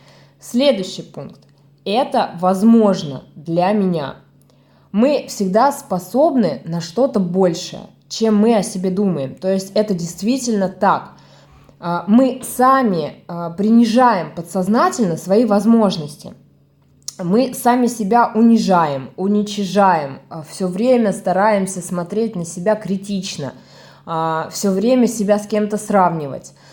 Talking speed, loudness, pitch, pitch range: 105 wpm, -17 LUFS, 200 Hz, 175-225 Hz